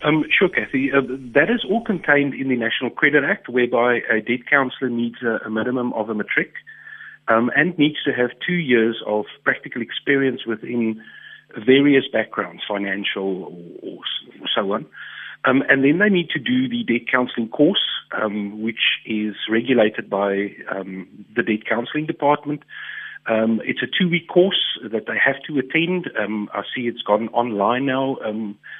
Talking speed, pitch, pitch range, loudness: 170 wpm, 125 Hz, 110-145 Hz, -20 LUFS